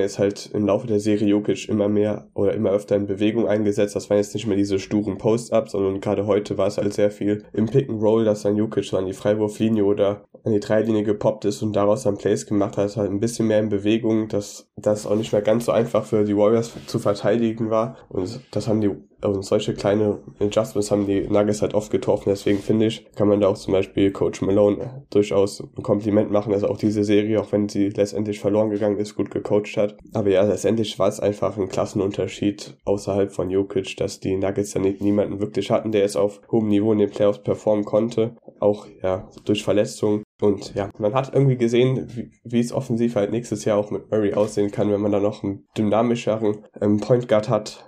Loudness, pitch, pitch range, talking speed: -22 LUFS, 105 Hz, 100-110 Hz, 220 wpm